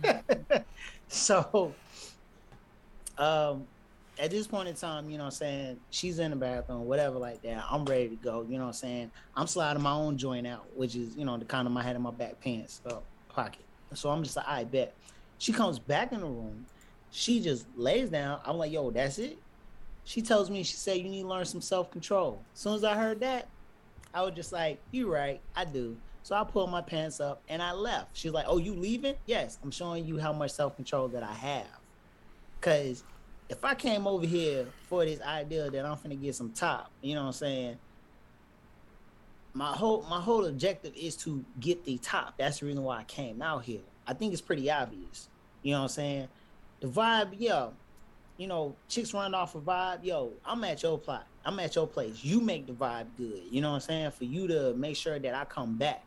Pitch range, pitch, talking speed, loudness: 130-180 Hz, 150 Hz, 225 wpm, -33 LUFS